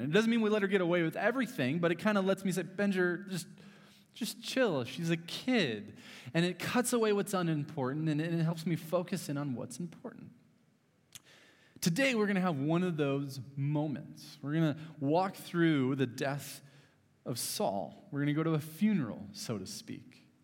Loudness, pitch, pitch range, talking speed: -33 LUFS, 170 Hz, 145-195 Hz, 195 wpm